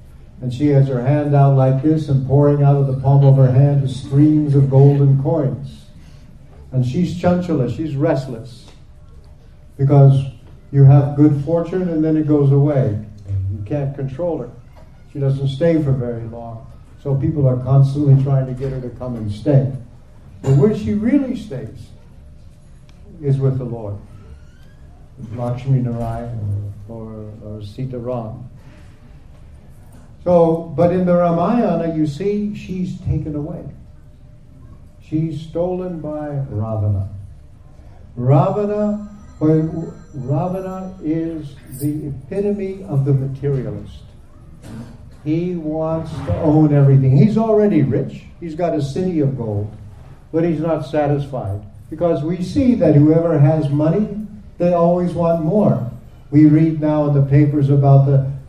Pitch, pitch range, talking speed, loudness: 140 Hz, 125-160 Hz, 135 wpm, -17 LUFS